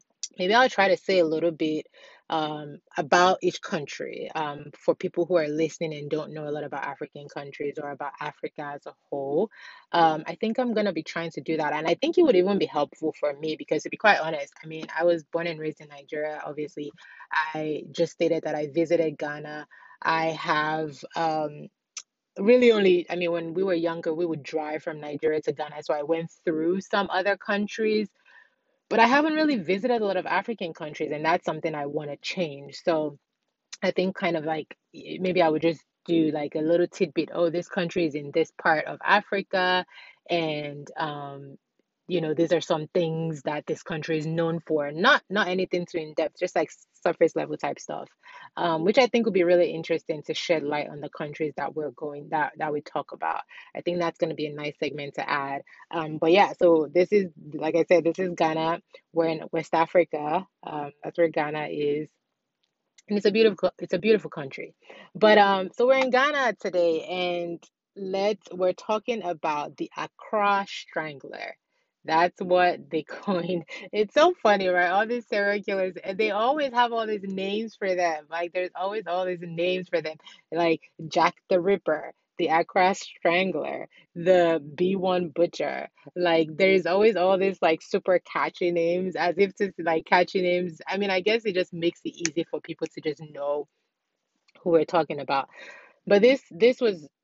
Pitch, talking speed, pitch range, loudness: 170 Hz, 195 wpm, 155-190 Hz, -26 LUFS